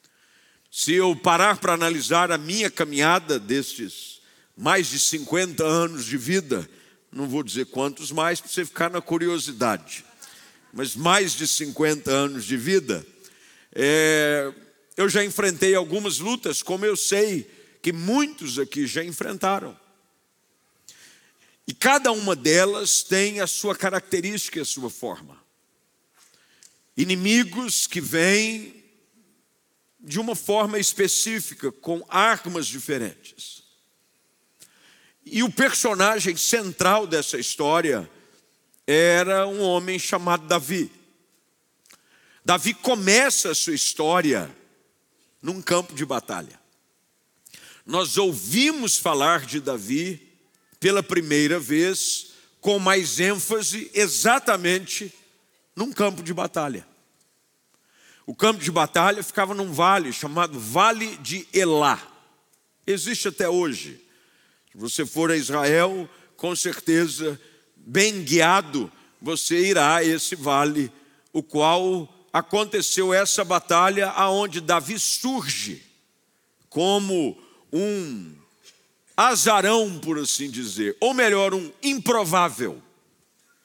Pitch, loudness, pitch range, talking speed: 180 Hz, -22 LUFS, 160-205 Hz, 110 wpm